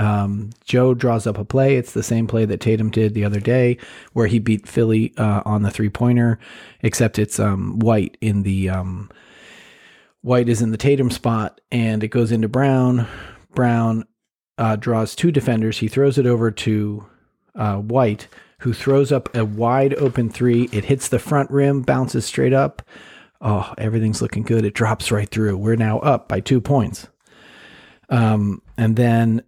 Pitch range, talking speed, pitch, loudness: 105-125 Hz, 175 wpm, 115 Hz, -19 LUFS